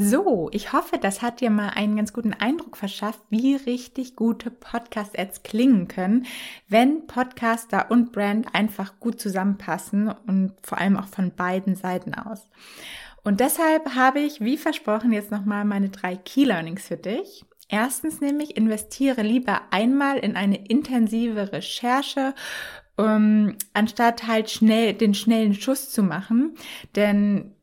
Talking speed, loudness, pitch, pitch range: 140 wpm, -23 LUFS, 220 Hz, 205-250 Hz